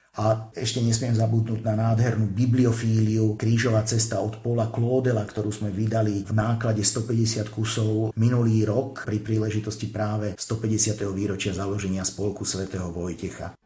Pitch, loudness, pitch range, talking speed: 110 Hz, -24 LUFS, 105-115 Hz, 130 wpm